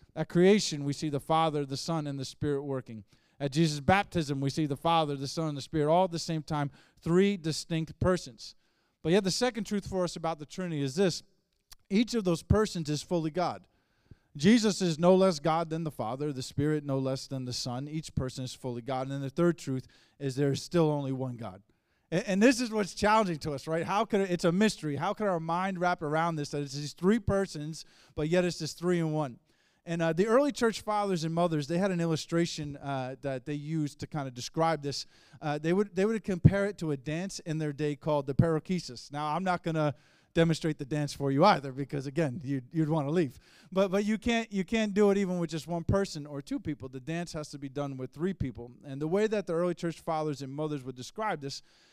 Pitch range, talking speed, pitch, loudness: 140-180 Hz, 240 wpm, 160 Hz, -30 LUFS